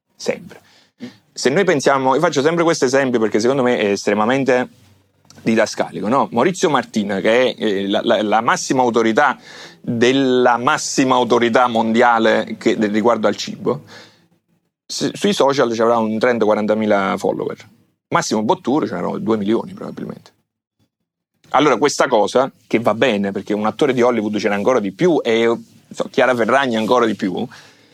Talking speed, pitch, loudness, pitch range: 150 wpm, 115 Hz, -17 LUFS, 110-125 Hz